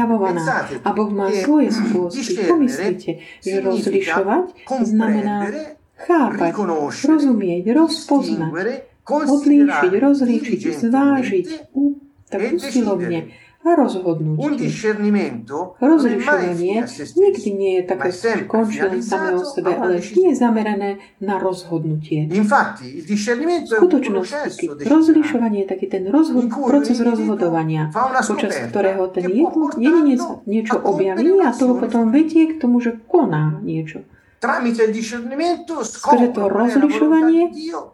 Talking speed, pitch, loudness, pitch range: 100 wpm, 235 Hz, -18 LUFS, 195-290 Hz